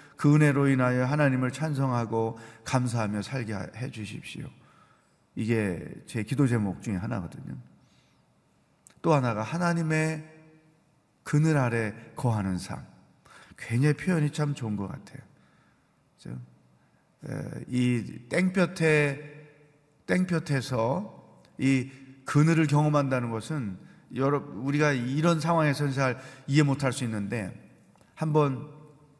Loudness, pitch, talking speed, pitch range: -27 LUFS, 135 Hz, 235 characters per minute, 115-150 Hz